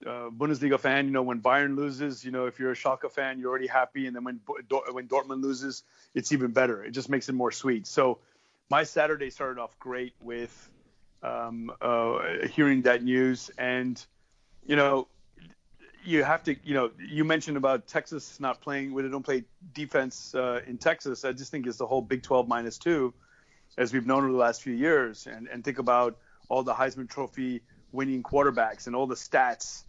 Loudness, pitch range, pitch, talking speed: -28 LUFS, 125-135 Hz, 130 Hz, 195 wpm